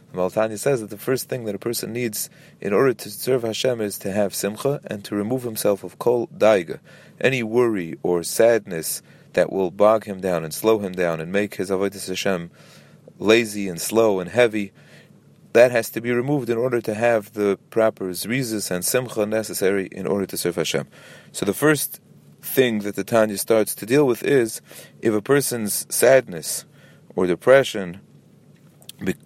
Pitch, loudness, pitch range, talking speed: 110 Hz, -21 LUFS, 100-120 Hz, 185 wpm